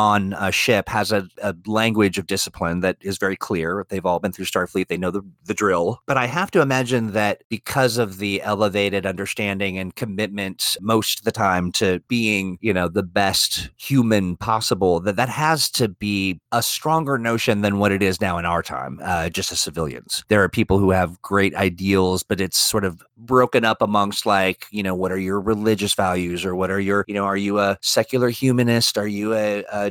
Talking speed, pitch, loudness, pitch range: 210 wpm, 100 Hz, -20 LUFS, 95-110 Hz